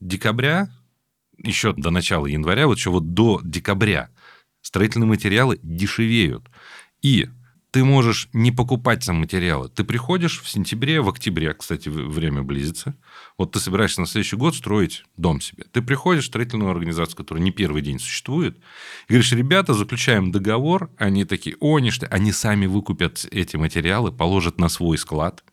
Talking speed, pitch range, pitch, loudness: 155 wpm, 85-120 Hz, 105 Hz, -21 LUFS